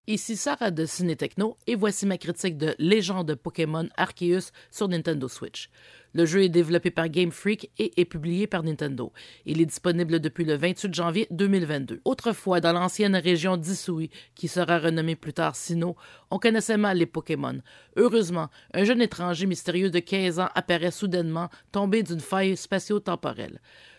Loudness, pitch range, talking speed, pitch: -26 LUFS, 165-195 Hz, 165 wpm, 175 Hz